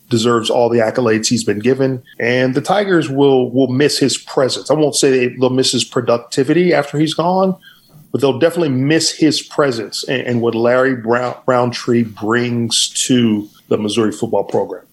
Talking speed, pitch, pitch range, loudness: 175 wpm, 130 Hz, 120-145 Hz, -15 LUFS